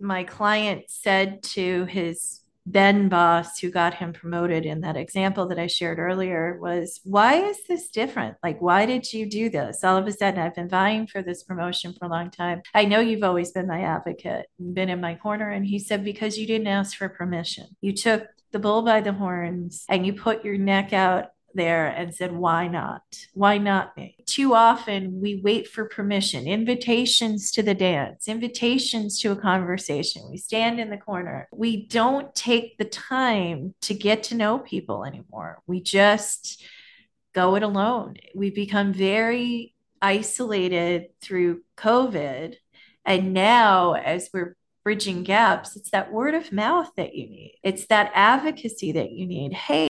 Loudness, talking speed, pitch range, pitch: -23 LUFS, 175 wpm, 180-220 Hz, 200 Hz